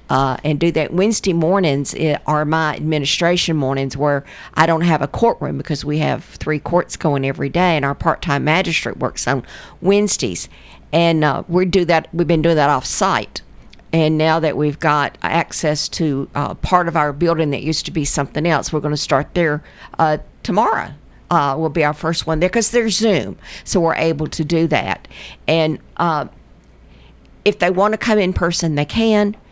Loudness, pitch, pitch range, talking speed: -17 LUFS, 160 Hz, 145-170 Hz, 190 wpm